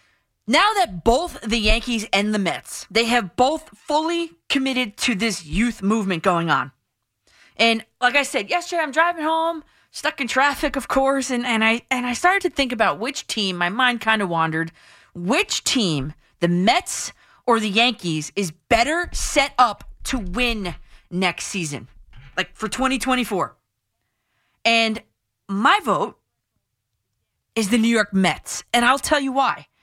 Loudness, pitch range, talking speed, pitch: -20 LUFS, 185-270 Hz, 160 wpm, 230 Hz